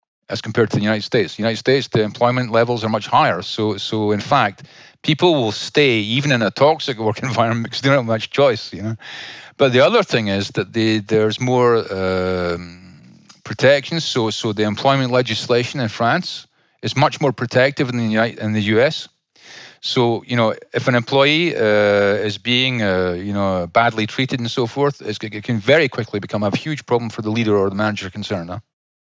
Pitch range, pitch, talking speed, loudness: 105-125 Hz, 115 Hz, 200 wpm, -18 LUFS